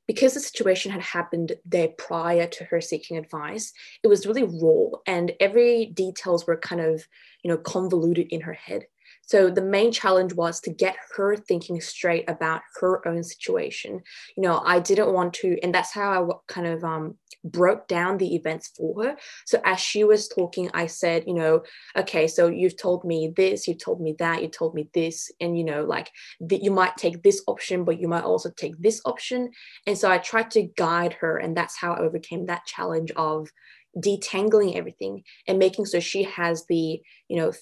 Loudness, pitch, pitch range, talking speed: -24 LUFS, 175 Hz, 165-200 Hz, 200 wpm